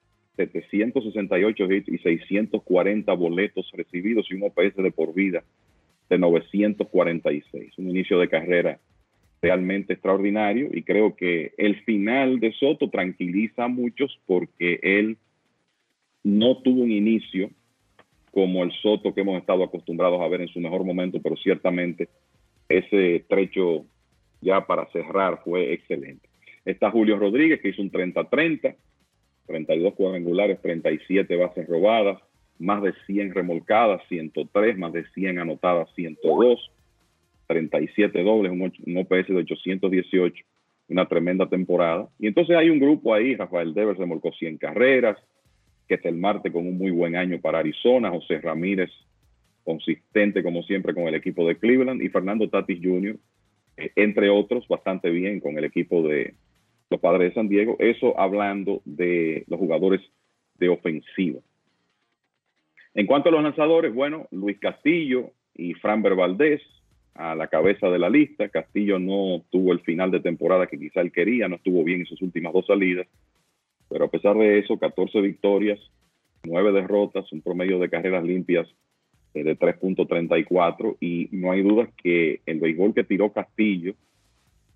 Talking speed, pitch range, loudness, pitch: 145 wpm, 90-105 Hz, -23 LUFS, 95 Hz